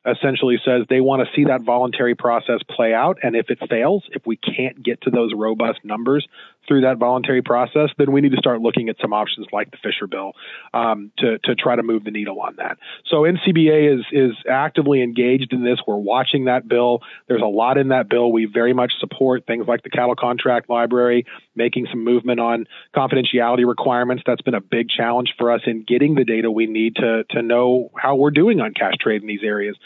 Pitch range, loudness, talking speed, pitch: 115-130 Hz, -18 LUFS, 220 wpm, 120 Hz